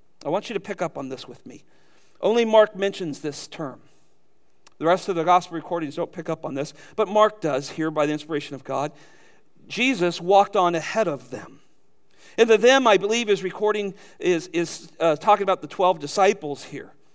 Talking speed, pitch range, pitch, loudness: 200 wpm, 150-200 Hz, 175 Hz, -22 LUFS